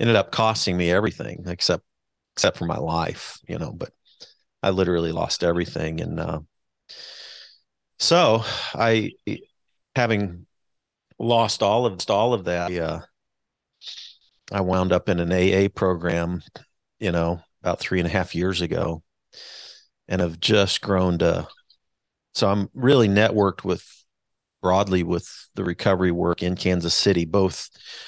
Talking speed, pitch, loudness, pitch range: 135 wpm, 90 Hz, -22 LUFS, 85-100 Hz